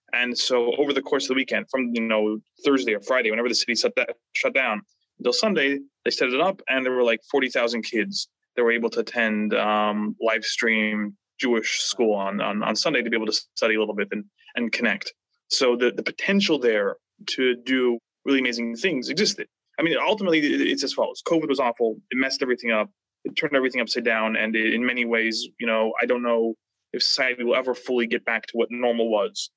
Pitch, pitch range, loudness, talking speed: 120 Hz, 110-130 Hz, -23 LUFS, 215 wpm